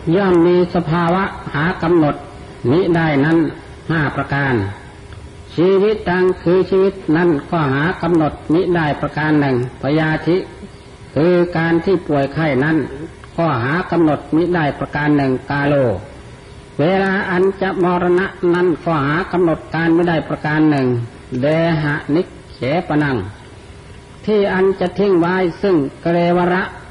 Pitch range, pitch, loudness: 145-180 Hz, 165 Hz, -16 LUFS